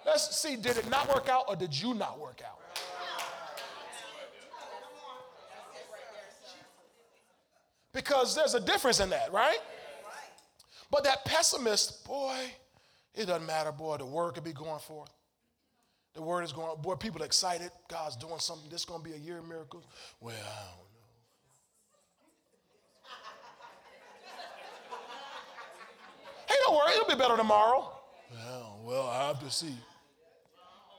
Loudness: -31 LUFS